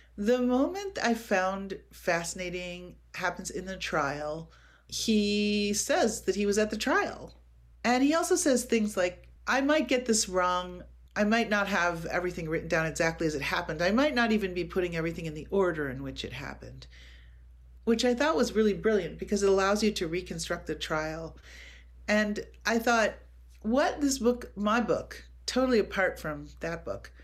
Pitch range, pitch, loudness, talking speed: 160-225 Hz, 190 Hz, -29 LUFS, 175 wpm